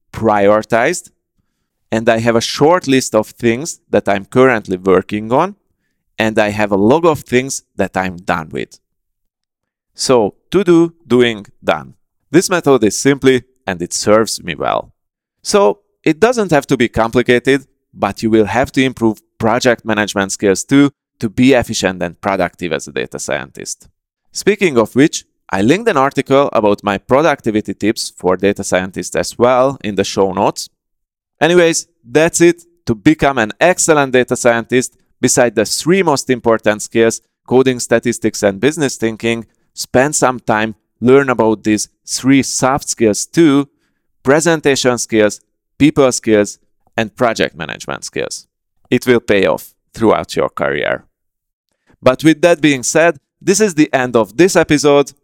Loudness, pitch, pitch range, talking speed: -14 LUFS, 120 Hz, 105-140 Hz, 155 wpm